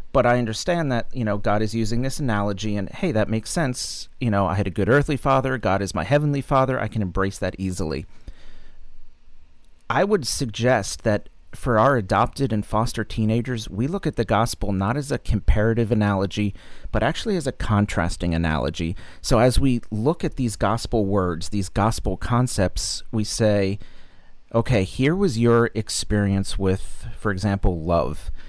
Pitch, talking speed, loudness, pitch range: 105 Hz, 175 wpm, -23 LUFS, 95-120 Hz